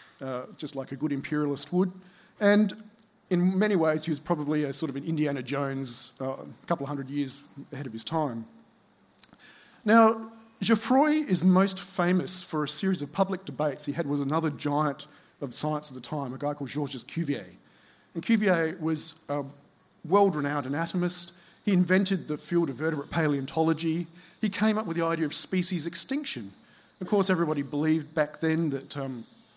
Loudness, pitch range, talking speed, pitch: -27 LUFS, 145-185 Hz, 175 wpm, 160 Hz